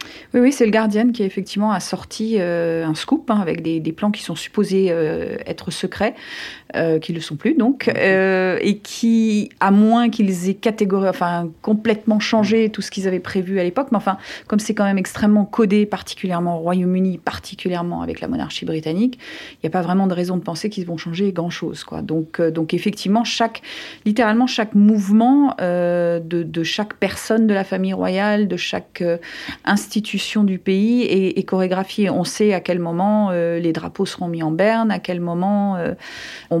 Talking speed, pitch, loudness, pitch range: 200 wpm, 195 Hz, -19 LUFS, 175-215 Hz